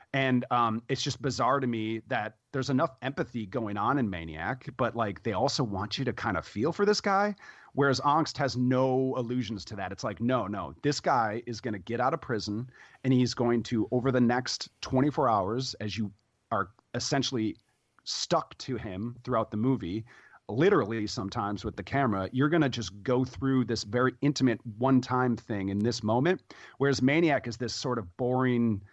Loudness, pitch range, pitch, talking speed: -29 LUFS, 110-130 Hz, 125 Hz, 195 wpm